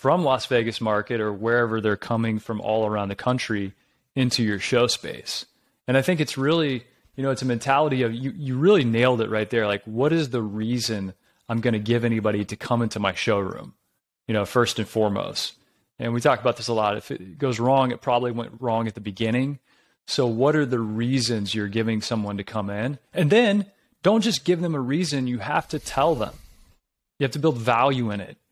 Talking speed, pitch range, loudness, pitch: 220 wpm, 110-135 Hz, -24 LUFS, 120 Hz